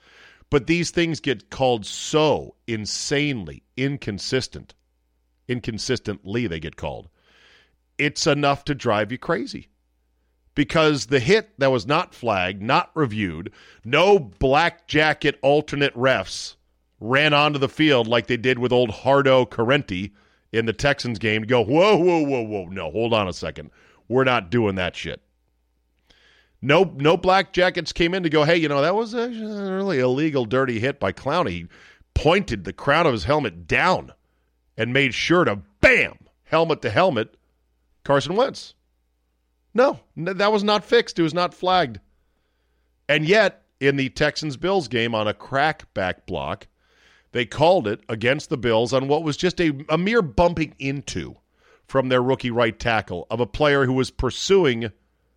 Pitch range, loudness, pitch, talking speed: 95-150 Hz, -21 LUFS, 130 Hz, 160 wpm